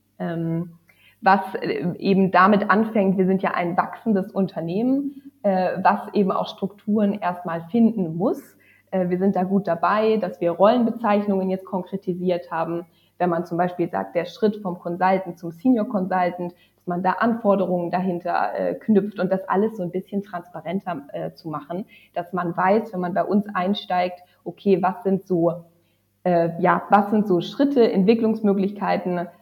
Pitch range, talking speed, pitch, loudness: 175-200 Hz, 160 wpm, 185 Hz, -22 LUFS